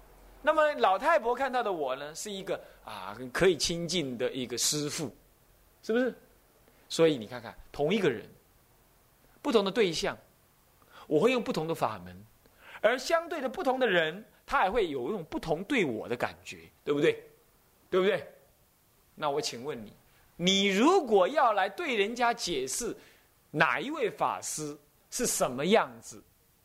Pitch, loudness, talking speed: 175 Hz, -29 LUFS, 225 characters per minute